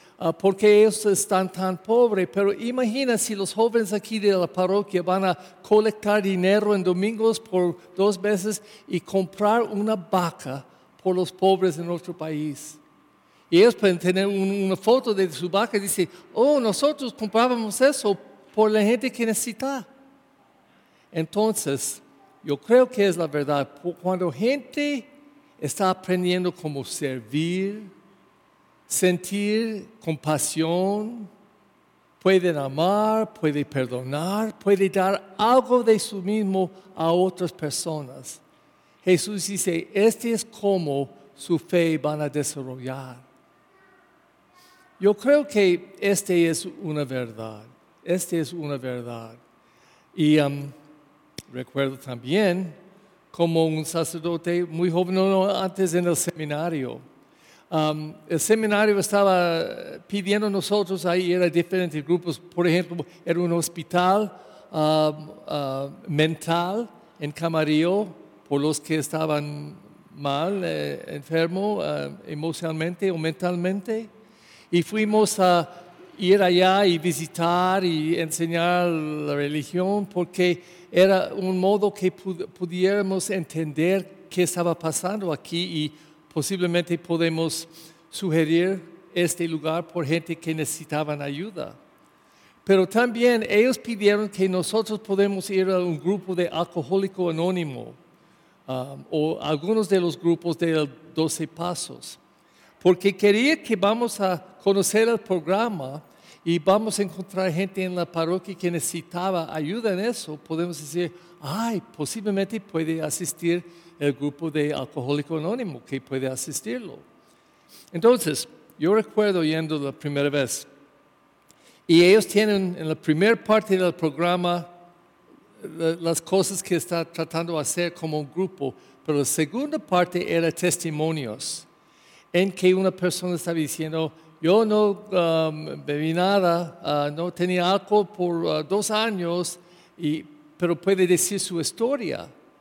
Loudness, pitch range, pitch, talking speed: -24 LUFS, 160-200 Hz, 180 Hz, 125 wpm